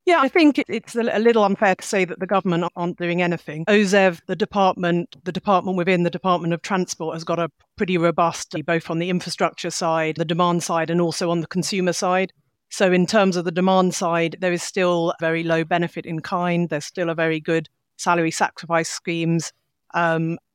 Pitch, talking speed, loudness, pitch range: 175 Hz, 200 wpm, -21 LUFS, 165-185 Hz